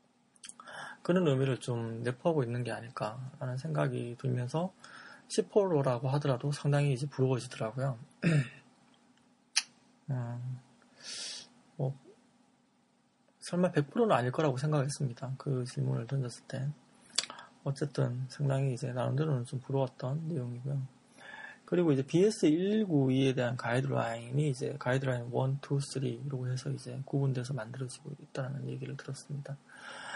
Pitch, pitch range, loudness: 135 Hz, 130-150 Hz, -33 LUFS